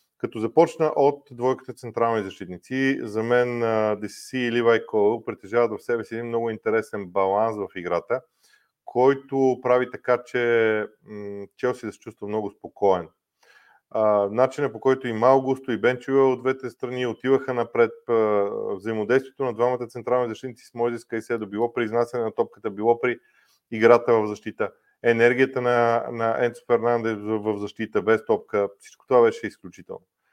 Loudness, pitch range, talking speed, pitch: -23 LUFS, 110-125 Hz, 150 wpm, 120 Hz